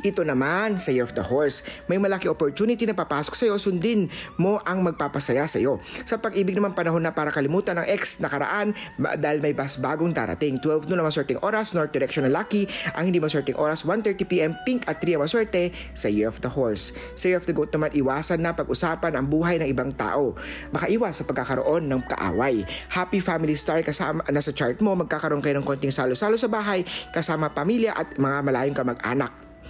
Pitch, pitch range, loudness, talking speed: 160 Hz, 145-195 Hz, -24 LUFS, 195 wpm